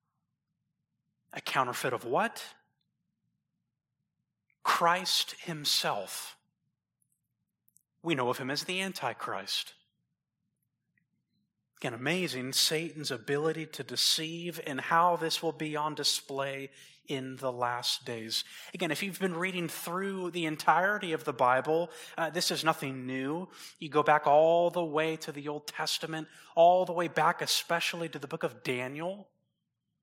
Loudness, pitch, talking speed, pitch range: -30 LUFS, 155 Hz, 130 wpm, 140-170 Hz